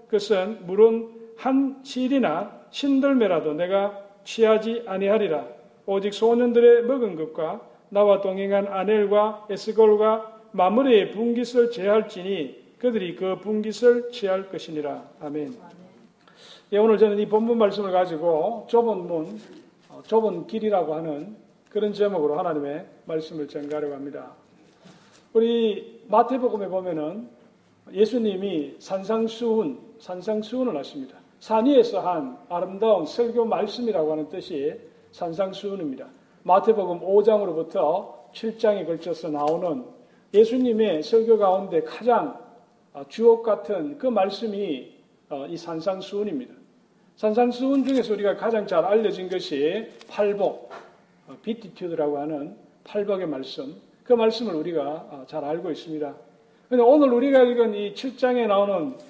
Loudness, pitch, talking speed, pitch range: -23 LUFS, 210 Hz, 285 characters per minute, 185-230 Hz